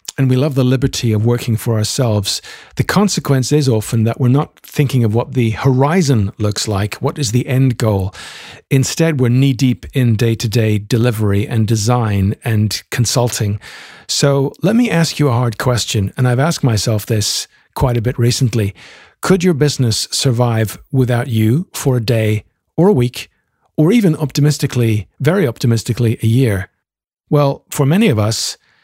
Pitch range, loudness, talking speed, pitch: 110-140 Hz, -15 LUFS, 170 wpm, 125 Hz